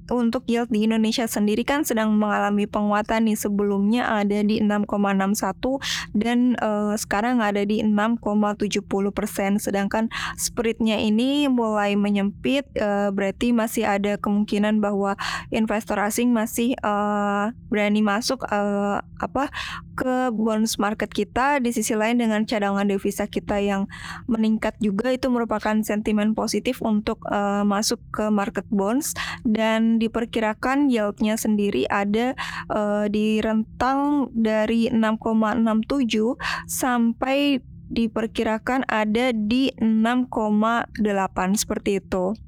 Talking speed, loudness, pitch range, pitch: 115 wpm, -22 LUFS, 205-235 Hz, 215 Hz